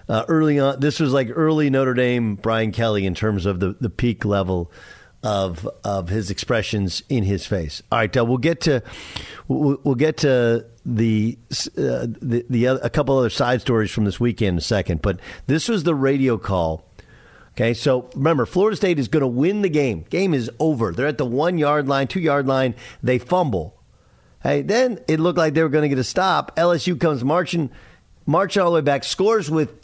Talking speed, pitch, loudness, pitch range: 205 wpm, 125 Hz, -20 LUFS, 110-155 Hz